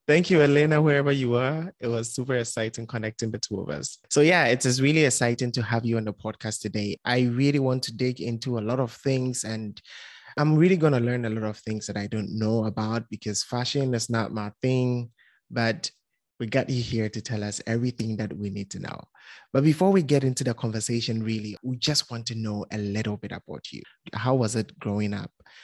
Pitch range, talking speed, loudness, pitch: 110-130 Hz, 225 wpm, -26 LUFS, 115 Hz